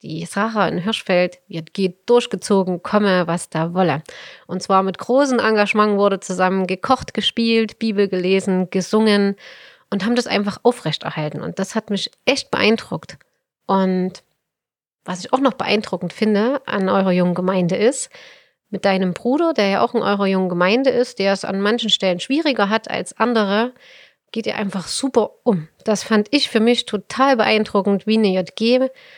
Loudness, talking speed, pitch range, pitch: -18 LUFS, 165 wpm, 185-225 Hz, 200 Hz